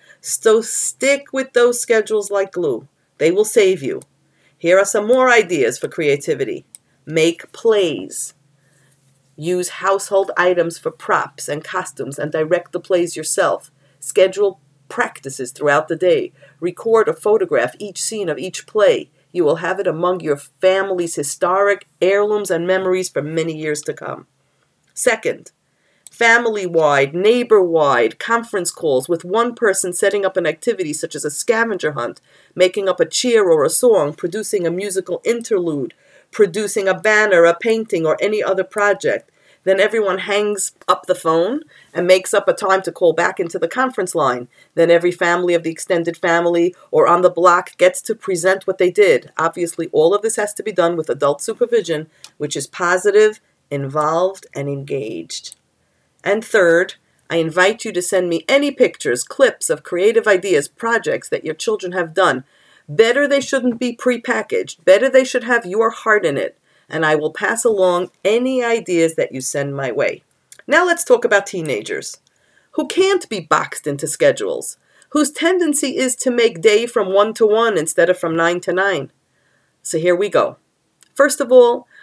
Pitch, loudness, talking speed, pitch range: 195 Hz, -17 LUFS, 170 wpm, 170-240 Hz